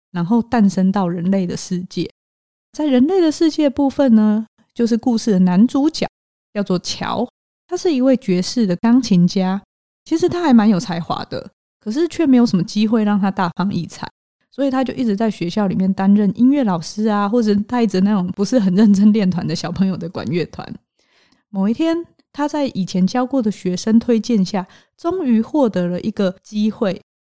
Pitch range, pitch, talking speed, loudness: 190-250 Hz, 215 Hz, 280 characters per minute, -17 LUFS